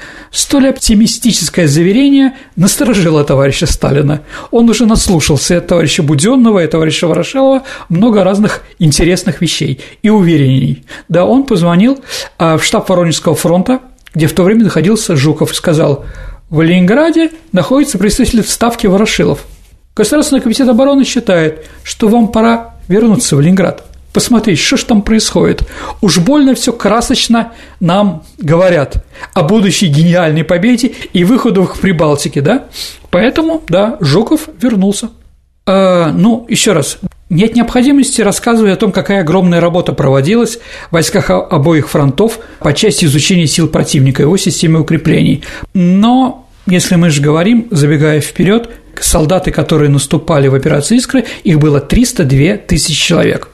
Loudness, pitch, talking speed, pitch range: -10 LUFS, 185 Hz, 135 wpm, 160-230 Hz